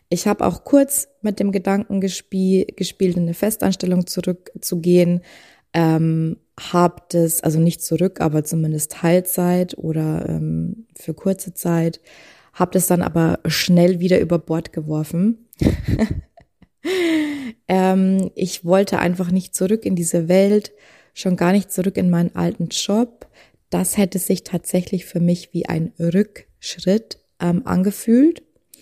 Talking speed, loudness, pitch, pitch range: 135 wpm, -19 LUFS, 180 Hz, 170-195 Hz